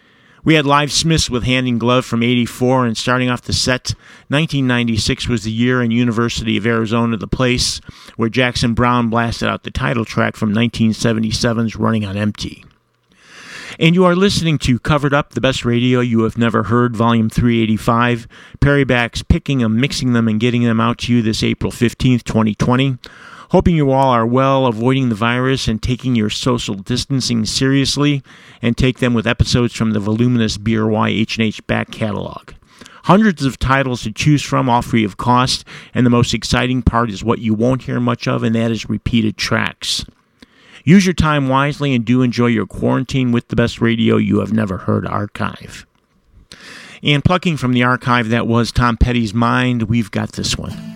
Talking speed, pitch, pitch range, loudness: 180 wpm, 120 Hz, 115-130 Hz, -16 LUFS